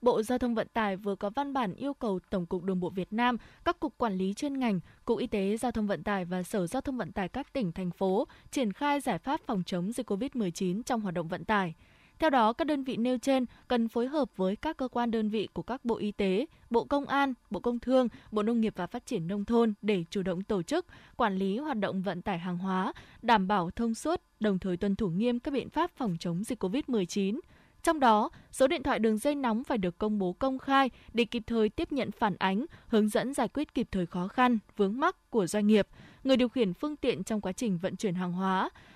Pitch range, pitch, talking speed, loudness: 195-255 Hz, 225 Hz, 250 wpm, -31 LUFS